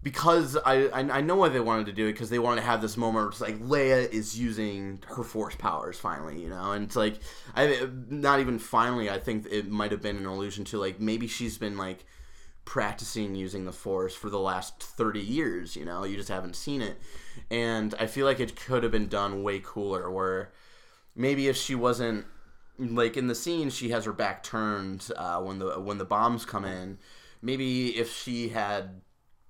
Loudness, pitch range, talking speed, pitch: -29 LUFS, 100-120 Hz, 210 wpm, 110 Hz